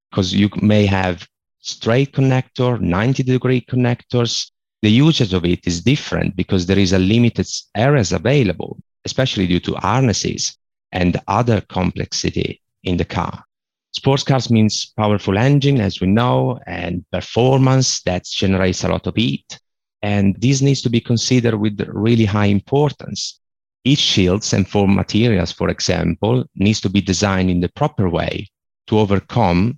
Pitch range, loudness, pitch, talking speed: 95-125 Hz, -17 LUFS, 105 Hz, 150 wpm